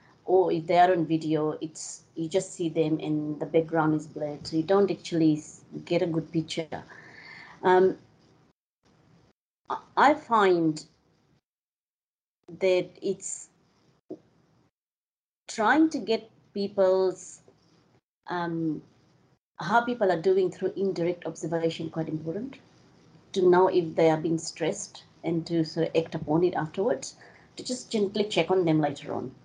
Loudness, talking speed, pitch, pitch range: -27 LUFS, 135 wpm, 170 Hz, 160-190 Hz